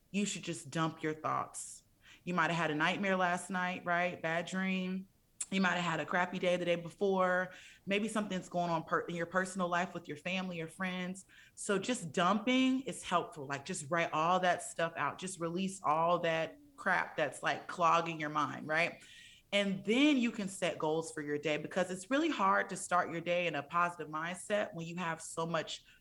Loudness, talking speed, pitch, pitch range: -34 LUFS, 210 wpm, 175 Hz, 165-190 Hz